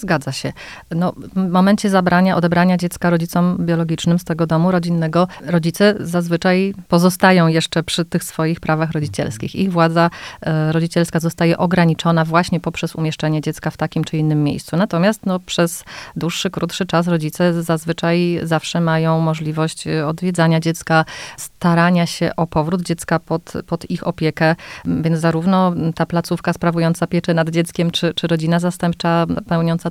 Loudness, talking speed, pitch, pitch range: -17 LUFS, 145 wpm, 170 Hz, 160-175 Hz